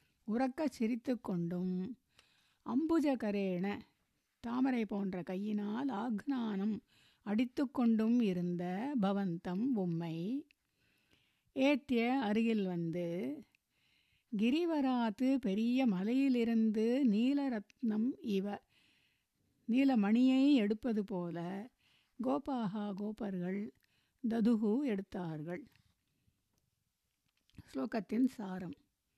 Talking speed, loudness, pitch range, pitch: 60 wpm, -35 LUFS, 200-255 Hz, 225 Hz